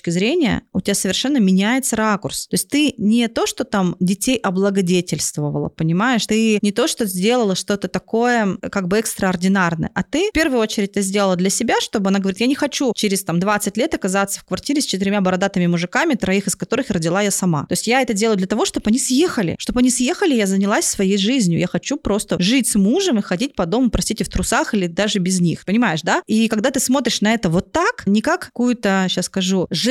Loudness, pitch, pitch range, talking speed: -18 LUFS, 205 Hz, 190-245 Hz, 215 wpm